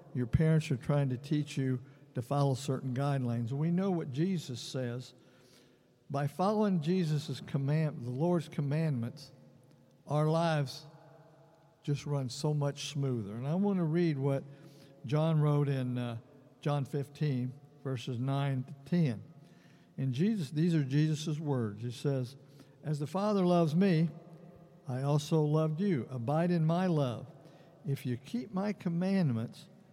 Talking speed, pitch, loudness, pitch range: 145 wpm, 145 Hz, -33 LUFS, 135-165 Hz